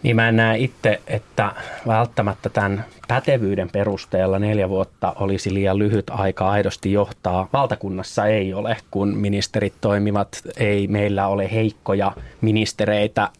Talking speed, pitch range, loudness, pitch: 130 wpm, 100-110 Hz, -21 LUFS, 100 Hz